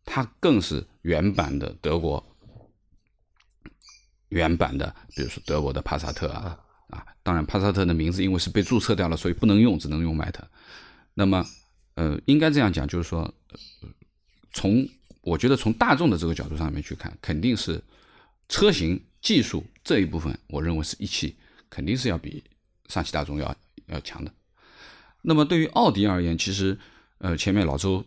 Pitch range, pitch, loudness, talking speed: 80-100 Hz, 90 Hz, -25 LUFS, 255 characters per minute